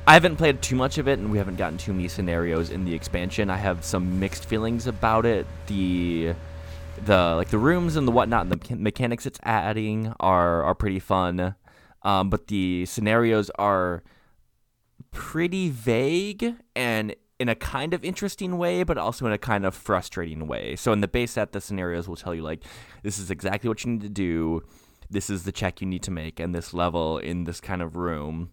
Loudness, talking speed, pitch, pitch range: -25 LUFS, 205 wpm, 100 Hz, 85-115 Hz